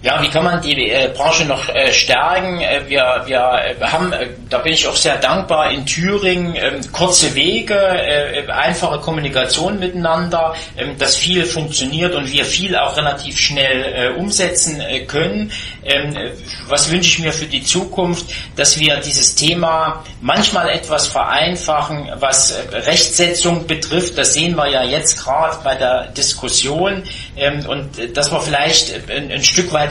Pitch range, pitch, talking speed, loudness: 140-175 Hz, 155 Hz, 165 wpm, -14 LUFS